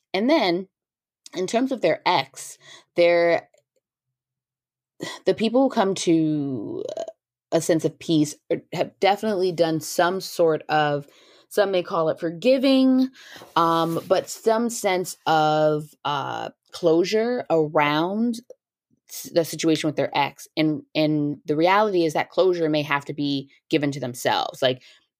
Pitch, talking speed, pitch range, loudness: 165 Hz, 130 wpm, 155-200 Hz, -22 LUFS